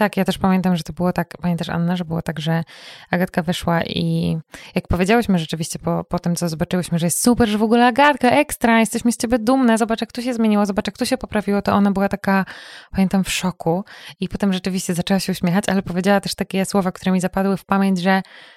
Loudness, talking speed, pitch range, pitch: -19 LUFS, 230 wpm, 175-210 Hz, 190 Hz